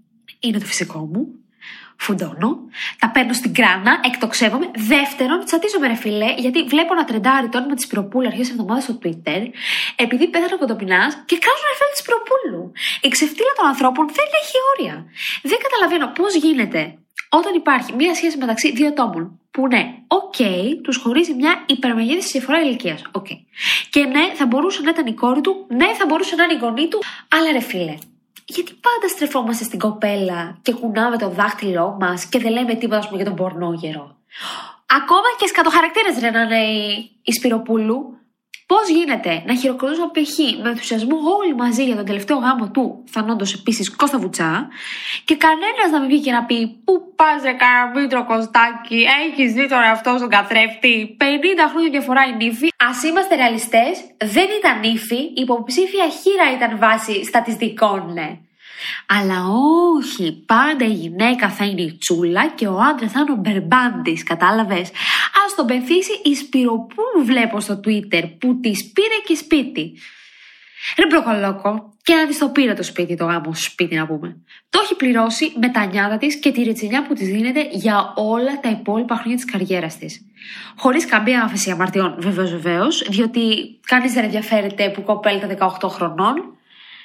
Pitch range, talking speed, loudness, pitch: 215-305 Hz, 170 wpm, -17 LUFS, 245 Hz